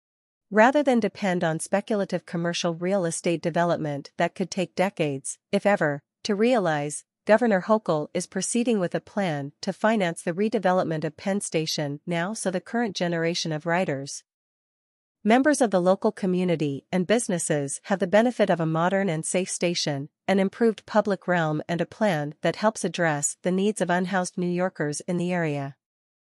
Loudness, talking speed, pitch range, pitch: -25 LUFS, 165 wpm, 160-200 Hz, 180 Hz